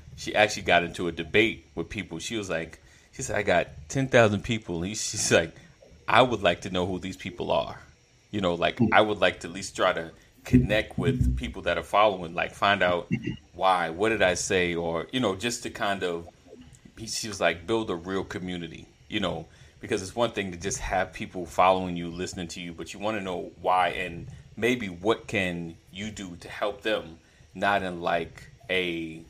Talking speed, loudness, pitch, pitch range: 210 wpm, -27 LUFS, 90 Hz, 85-105 Hz